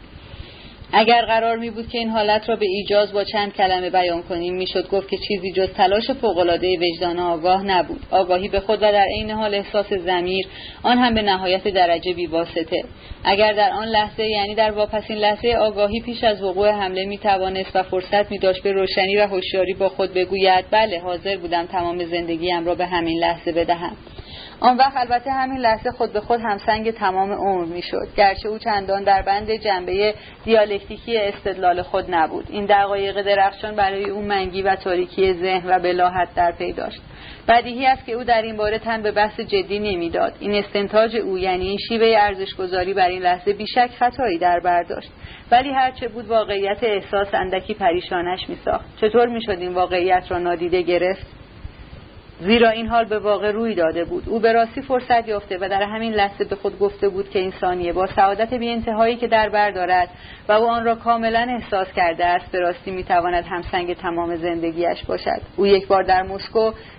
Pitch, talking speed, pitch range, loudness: 200 Hz, 185 wpm, 180-215 Hz, -20 LUFS